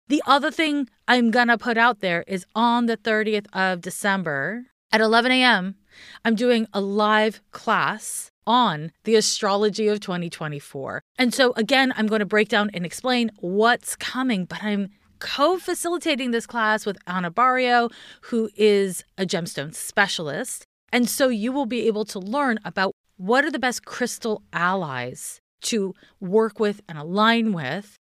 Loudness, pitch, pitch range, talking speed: -22 LUFS, 215 Hz, 190-245 Hz, 155 wpm